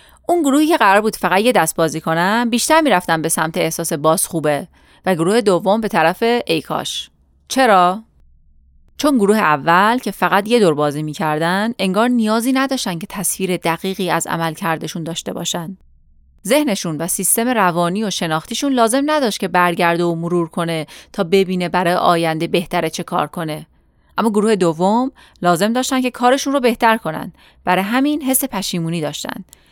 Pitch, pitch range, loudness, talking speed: 185 Hz, 165-230 Hz, -17 LUFS, 160 wpm